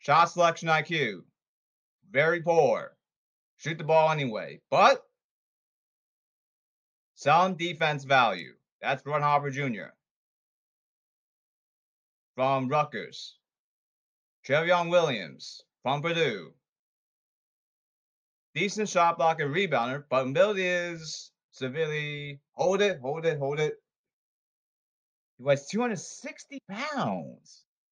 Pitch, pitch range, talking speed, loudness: 160 Hz, 145-185 Hz, 90 wpm, -27 LUFS